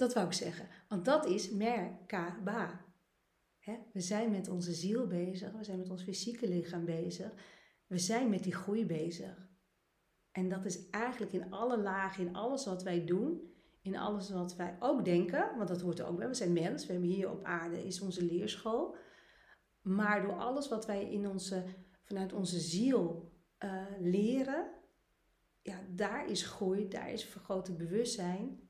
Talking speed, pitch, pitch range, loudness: 170 wpm, 190 Hz, 180-215 Hz, -37 LUFS